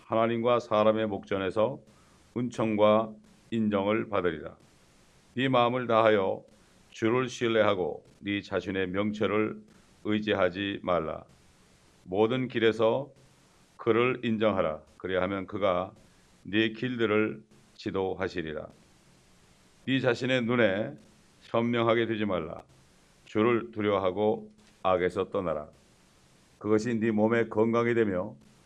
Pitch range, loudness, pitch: 100-115 Hz, -28 LUFS, 110 Hz